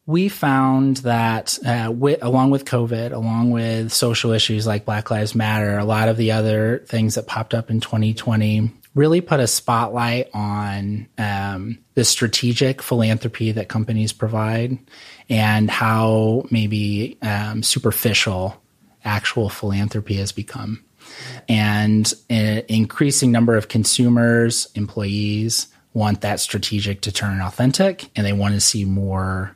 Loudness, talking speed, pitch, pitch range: -19 LUFS, 135 wpm, 110 Hz, 105-120 Hz